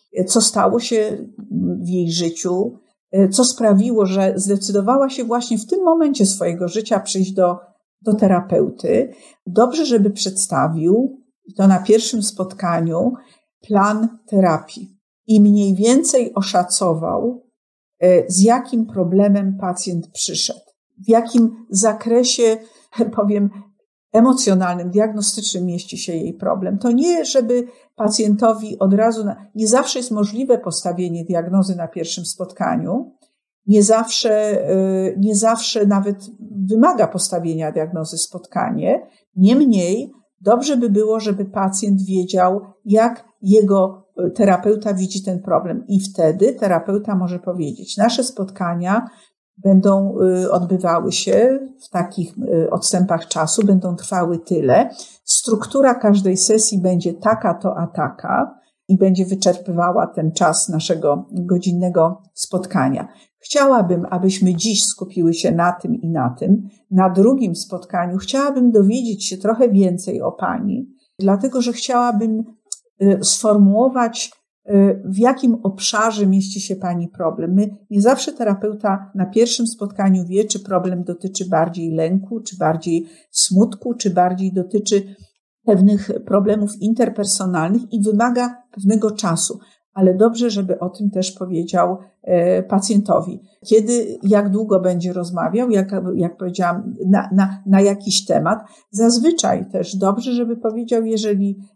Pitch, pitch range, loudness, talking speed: 200 Hz, 185-225 Hz, -17 LUFS, 120 wpm